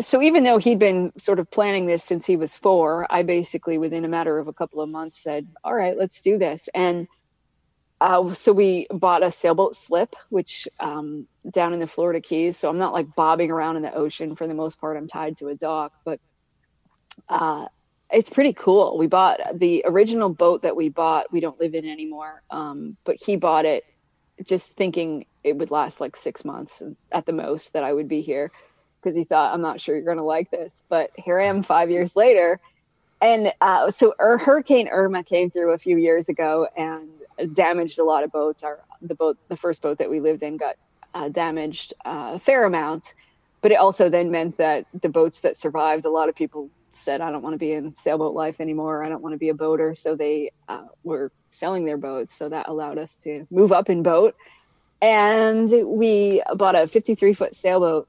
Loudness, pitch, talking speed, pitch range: -21 LUFS, 165 Hz, 215 wpm, 155-190 Hz